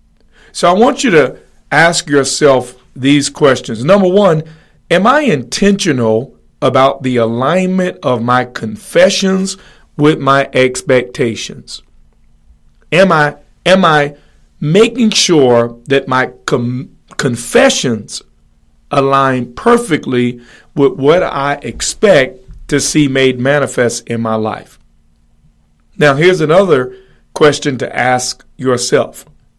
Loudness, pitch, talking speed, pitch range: -12 LUFS, 135 Hz, 105 wpm, 125-160 Hz